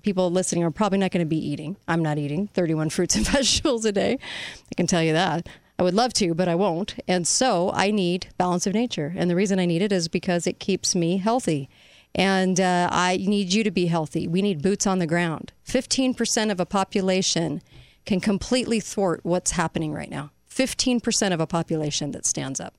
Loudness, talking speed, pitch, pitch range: -23 LUFS, 215 wpm, 185 Hz, 170-205 Hz